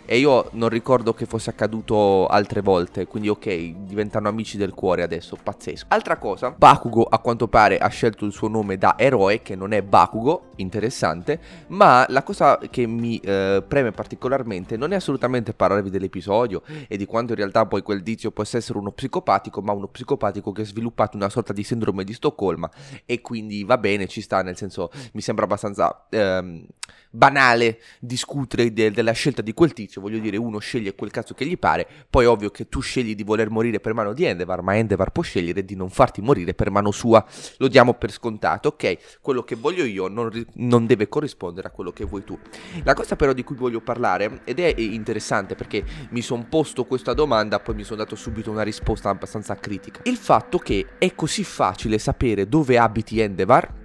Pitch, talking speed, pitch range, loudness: 110 Hz, 200 wpm, 100-120 Hz, -21 LUFS